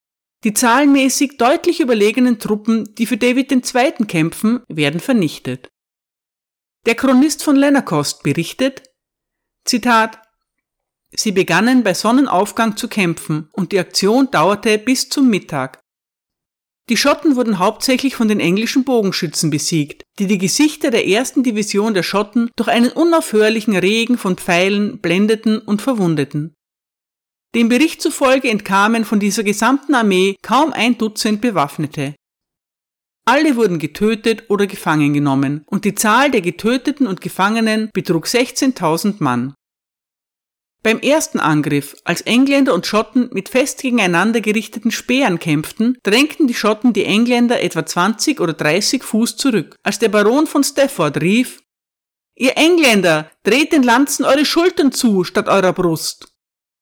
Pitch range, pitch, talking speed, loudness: 180-255 Hz, 220 Hz, 135 wpm, -15 LUFS